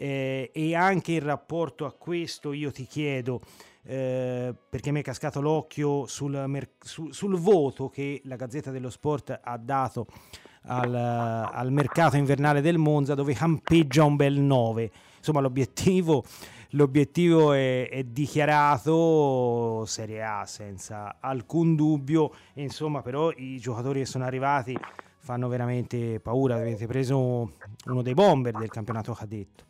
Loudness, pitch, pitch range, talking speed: -26 LUFS, 135 Hz, 120-150 Hz, 135 wpm